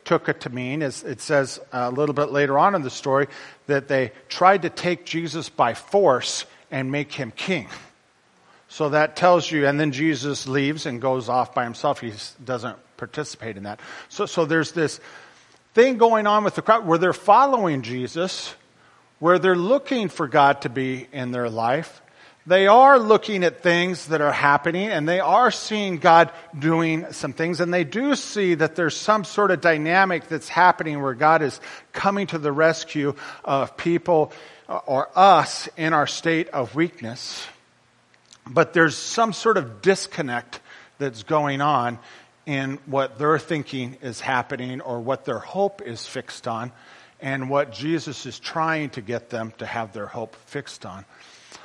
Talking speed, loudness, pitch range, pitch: 175 wpm, -21 LUFS, 130-175 Hz, 150 Hz